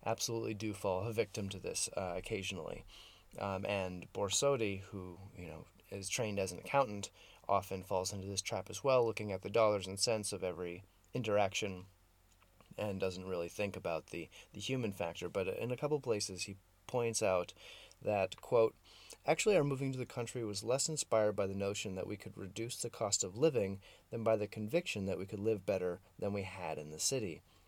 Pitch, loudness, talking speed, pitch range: 100 Hz, -37 LUFS, 195 wpm, 95-115 Hz